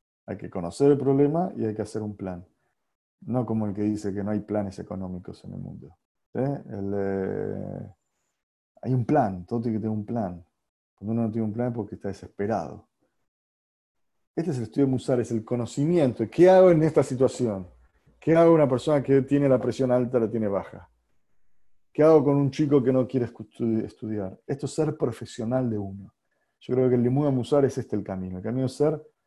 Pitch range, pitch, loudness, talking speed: 105-135 Hz, 115 Hz, -25 LUFS, 210 wpm